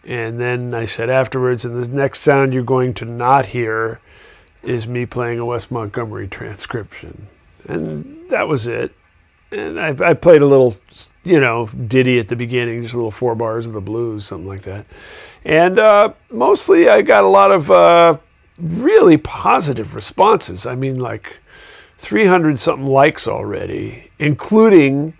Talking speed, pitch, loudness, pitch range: 160 wpm, 125 Hz, -14 LUFS, 115-145 Hz